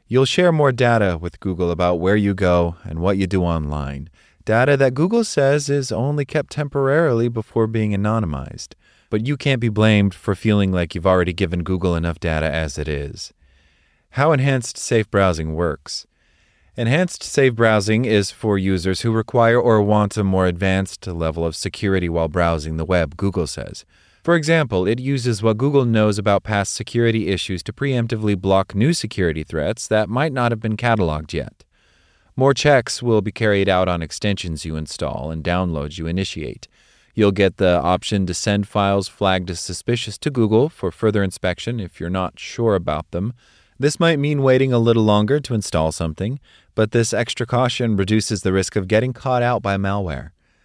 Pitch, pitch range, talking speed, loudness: 100 Hz, 90-120 Hz, 180 wpm, -19 LUFS